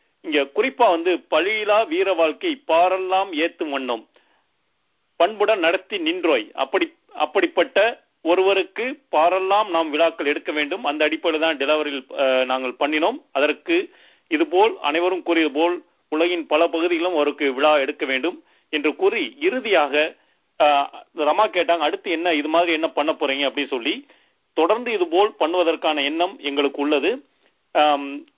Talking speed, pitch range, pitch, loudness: 120 wpm, 150-215 Hz, 170 Hz, -21 LUFS